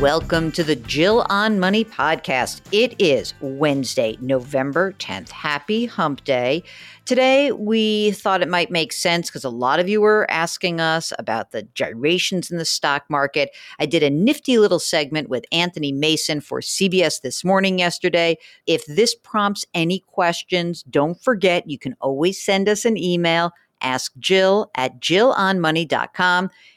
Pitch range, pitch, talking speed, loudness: 150-195 Hz, 170 Hz, 150 wpm, -19 LUFS